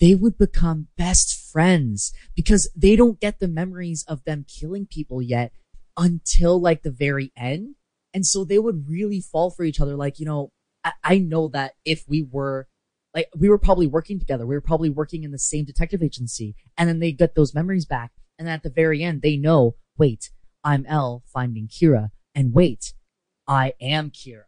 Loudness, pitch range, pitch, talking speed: -22 LUFS, 135-170 Hz, 155 Hz, 195 wpm